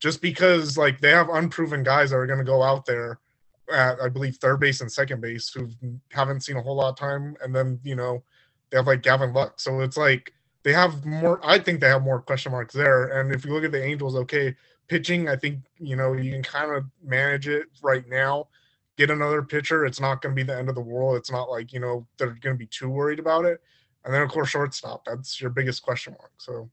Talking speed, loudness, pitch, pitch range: 250 wpm, -23 LUFS, 135 Hz, 130-145 Hz